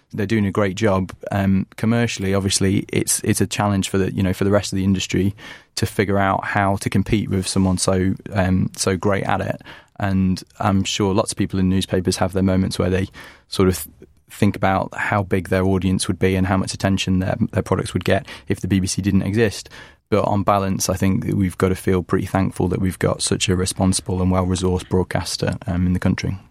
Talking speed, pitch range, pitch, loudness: 225 wpm, 95-100 Hz, 95 Hz, -20 LUFS